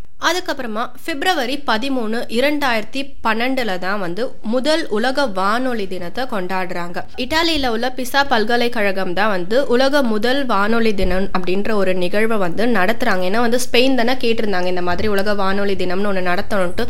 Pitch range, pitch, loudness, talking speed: 190-255 Hz, 225 Hz, -19 LUFS, 140 wpm